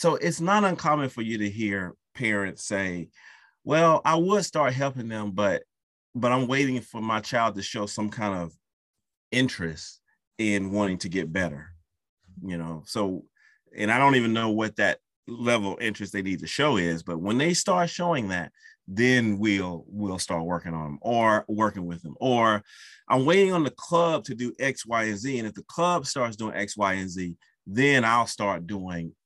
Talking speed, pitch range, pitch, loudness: 195 wpm, 95-125 Hz, 110 Hz, -26 LUFS